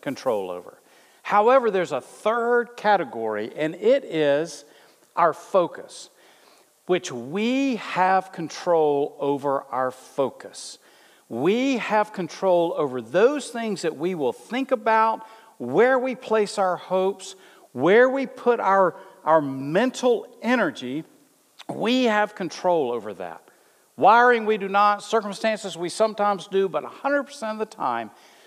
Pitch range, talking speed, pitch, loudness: 170-235 Hz, 125 wpm, 205 Hz, -23 LUFS